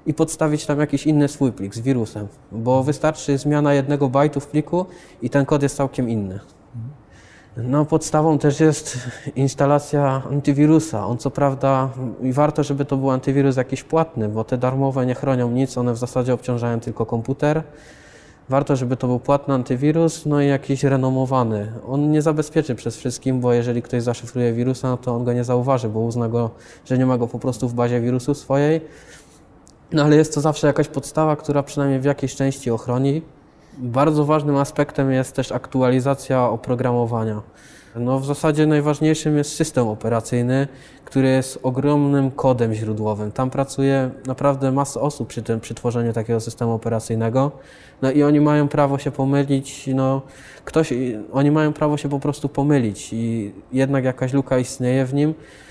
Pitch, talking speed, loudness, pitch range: 135 Hz, 170 wpm, -20 LUFS, 125-145 Hz